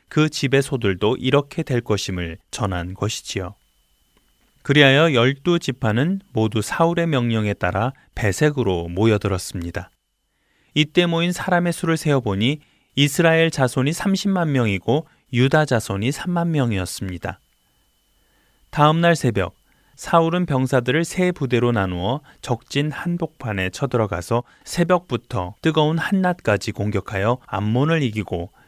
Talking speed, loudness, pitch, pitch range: 285 characters per minute, -20 LUFS, 130 Hz, 105-160 Hz